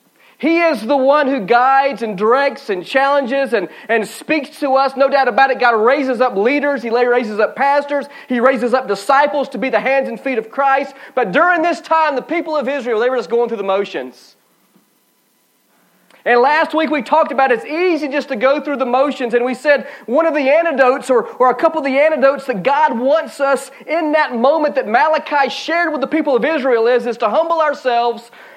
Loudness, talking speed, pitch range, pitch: -15 LUFS, 215 wpm, 245-295 Hz, 275 Hz